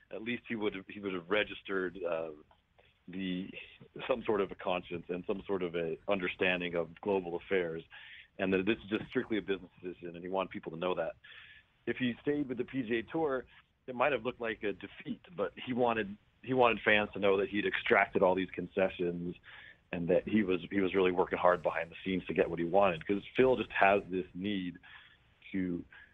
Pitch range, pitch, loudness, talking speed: 90-110 Hz, 100 Hz, -33 LUFS, 205 wpm